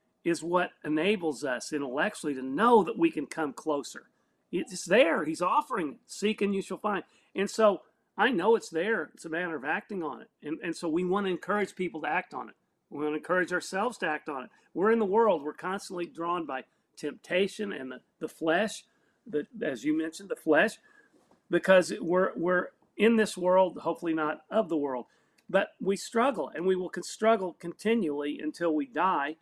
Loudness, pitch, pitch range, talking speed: -29 LUFS, 180 Hz, 155-200 Hz, 200 wpm